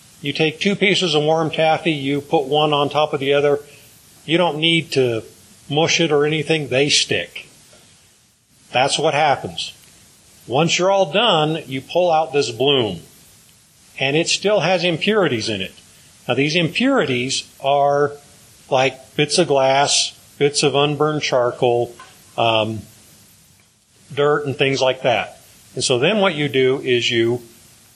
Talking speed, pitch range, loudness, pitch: 150 wpm, 130-160 Hz, -18 LUFS, 145 Hz